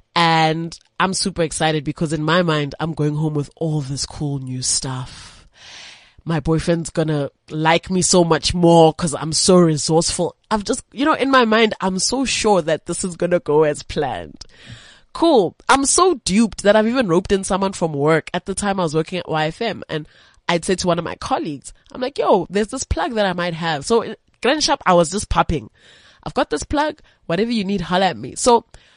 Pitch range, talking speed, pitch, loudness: 160-205 Hz, 215 wpm, 175 Hz, -18 LUFS